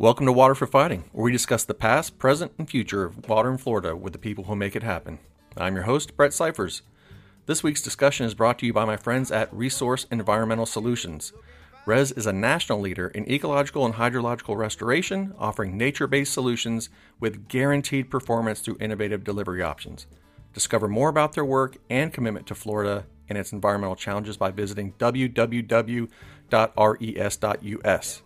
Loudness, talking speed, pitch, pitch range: -24 LUFS, 170 wpm, 115 Hz, 105-130 Hz